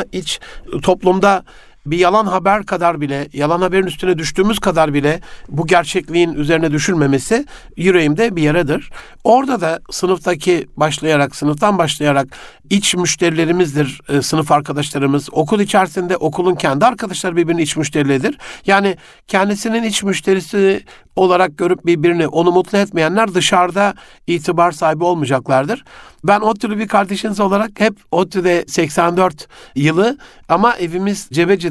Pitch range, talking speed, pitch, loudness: 155-195 Hz, 125 wpm, 180 Hz, -15 LUFS